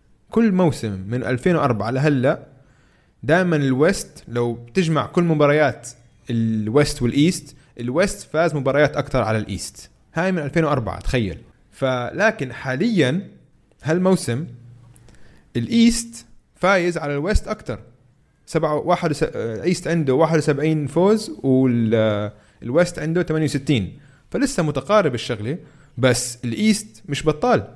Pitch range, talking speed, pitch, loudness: 120-165 Hz, 100 wpm, 145 Hz, -20 LUFS